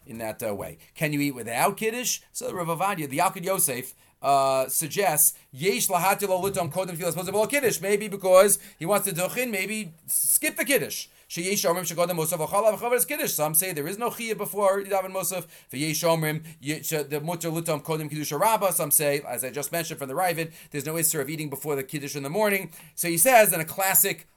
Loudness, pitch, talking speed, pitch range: -24 LUFS, 175 Hz, 165 wpm, 150-195 Hz